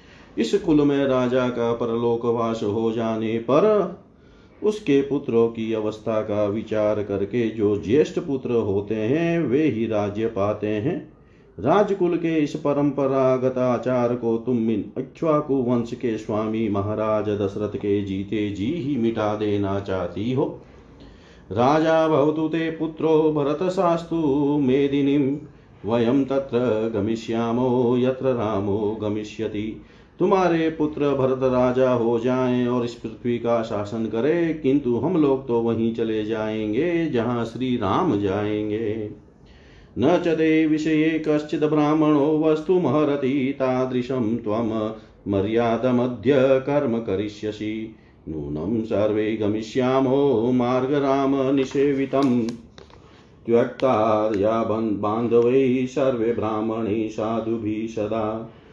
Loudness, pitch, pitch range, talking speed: -22 LUFS, 120 Hz, 110-140 Hz, 100 wpm